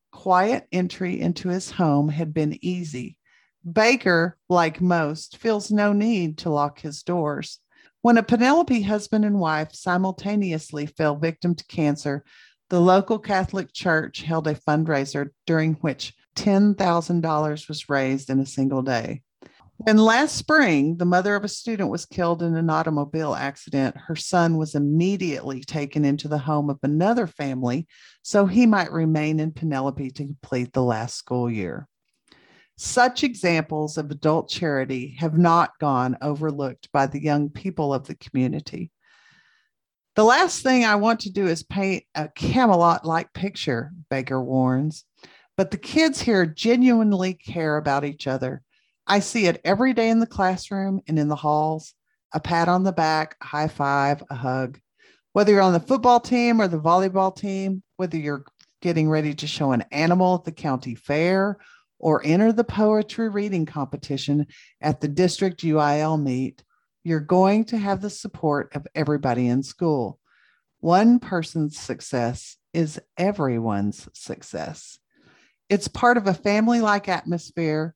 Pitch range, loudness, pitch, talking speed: 145-195 Hz, -22 LUFS, 165 Hz, 155 wpm